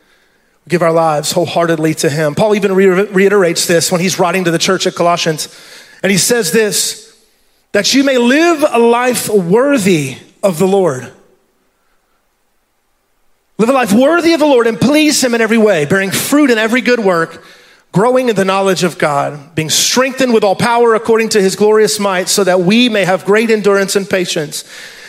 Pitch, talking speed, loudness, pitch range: 200 Hz, 180 wpm, -11 LUFS, 180-235 Hz